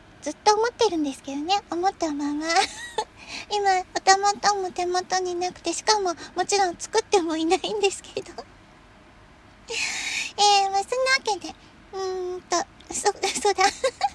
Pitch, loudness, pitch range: 390 Hz, -24 LUFS, 360-410 Hz